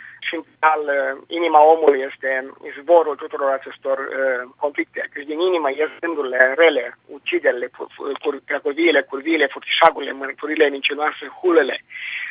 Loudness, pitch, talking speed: -19 LUFS, 170 Hz, 110 wpm